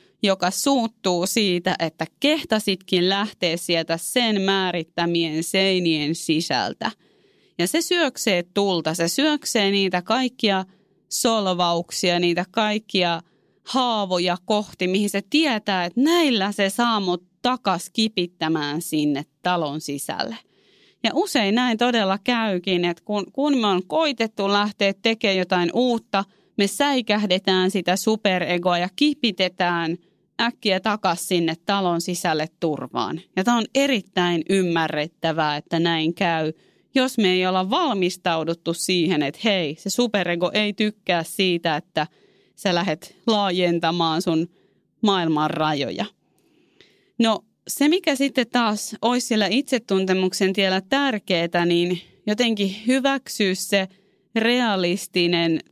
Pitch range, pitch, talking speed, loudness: 175-220 Hz, 190 Hz, 115 wpm, -22 LUFS